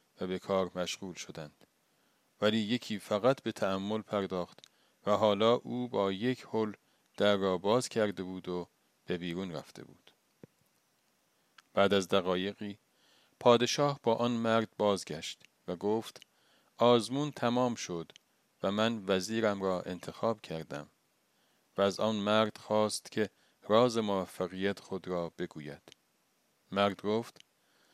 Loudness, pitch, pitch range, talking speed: -32 LUFS, 105 Hz, 95-115 Hz, 125 wpm